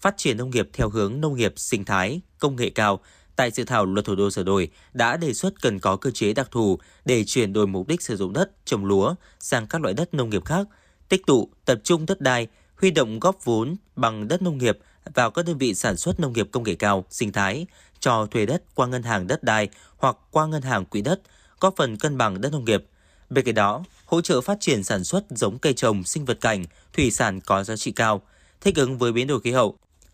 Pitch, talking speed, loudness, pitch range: 120 Hz, 245 wpm, -23 LUFS, 100-155 Hz